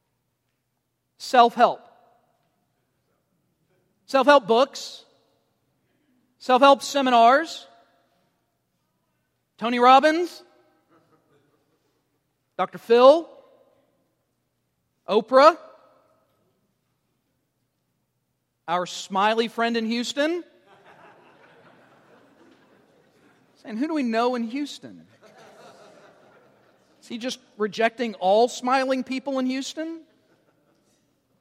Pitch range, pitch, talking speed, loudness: 200-275 Hz, 245 Hz, 65 wpm, -21 LUFS